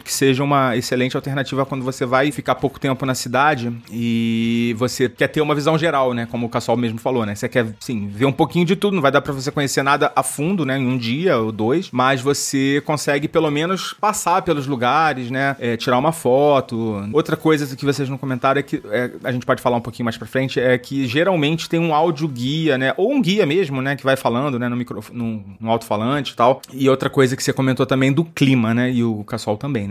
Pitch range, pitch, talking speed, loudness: 120-145 Hz, 135 Hz, 240 wpm, -19 LUFS